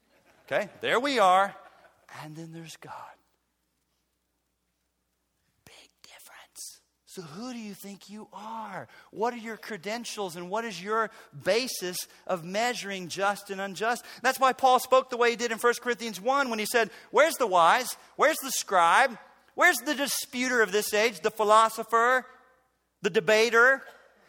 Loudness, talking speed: -26 LUFS, 155 wpm